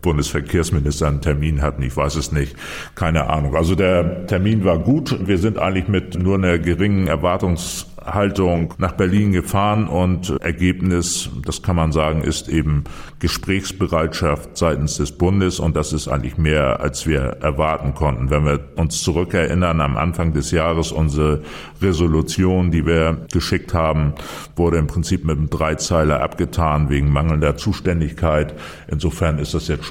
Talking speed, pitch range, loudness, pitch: 155 wpm, 75-90 Hz, -19 LUFS, 80 Hz